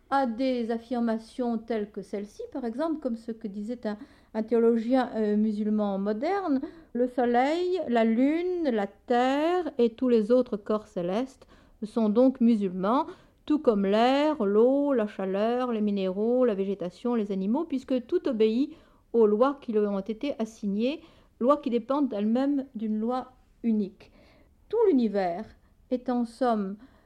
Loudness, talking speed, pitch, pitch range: -27 LUFS, 150 wpm, 235 Hz, 215-265 Hz